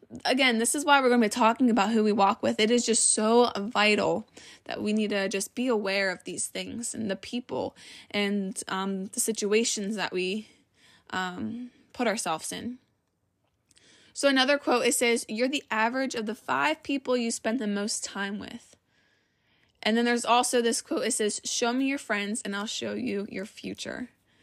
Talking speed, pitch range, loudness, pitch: 190 wpm, 205-245 Hz, -27 LUFS, 225 Hz